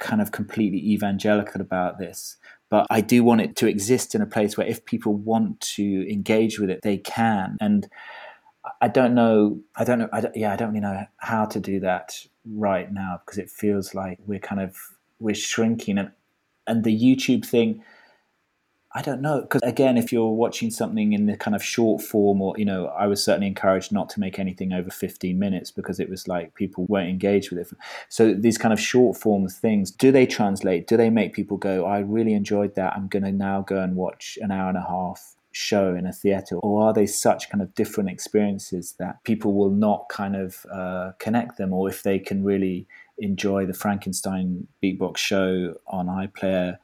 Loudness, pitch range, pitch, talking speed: -23 LUFS, 95-115 Hz, 100 Hz, 210 wpm